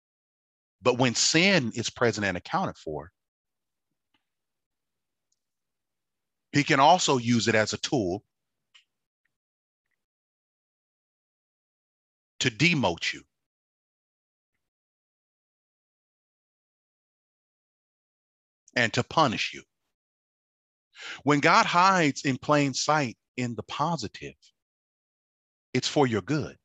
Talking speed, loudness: 80 wpm, -25 LUFS